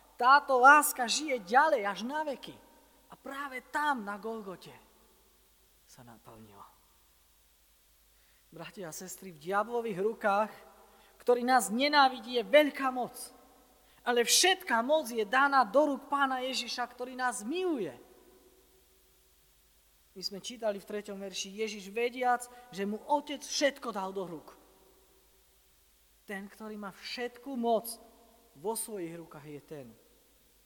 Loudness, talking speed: -30 LUFS, 125 wpm